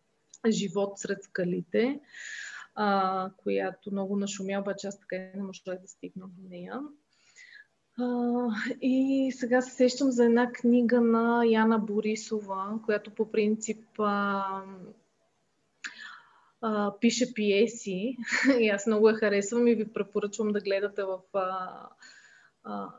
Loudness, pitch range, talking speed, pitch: -28 LUFS, 195-240 Hz, 125 wpm, 215 Hz